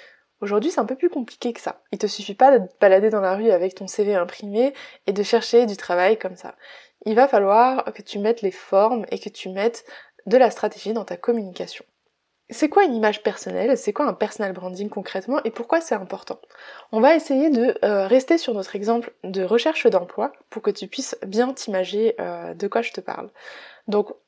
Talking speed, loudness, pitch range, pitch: 215 wpm, -21 LUFS, 200-245 Hz, 215 Hz